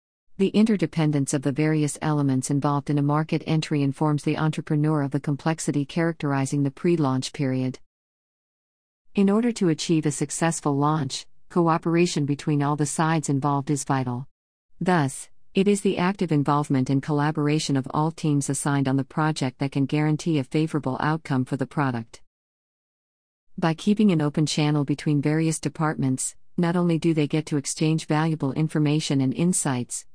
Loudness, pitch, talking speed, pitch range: -24 LUFS, 150 Hz, 160 wpm, 140-160 Hz